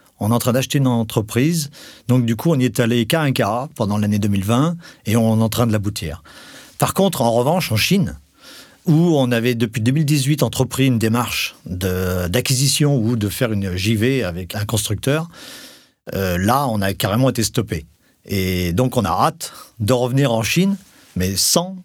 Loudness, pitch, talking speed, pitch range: -18 LUFS, 120 Hz, 190 wpm, 105-140 Hz